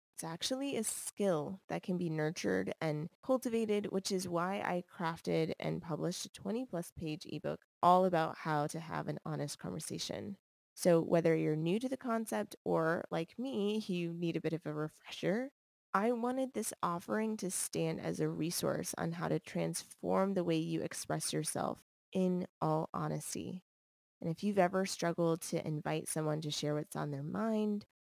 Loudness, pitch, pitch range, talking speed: -36 LUFS, 170 Hz, 155-195 Hz, 175 wpm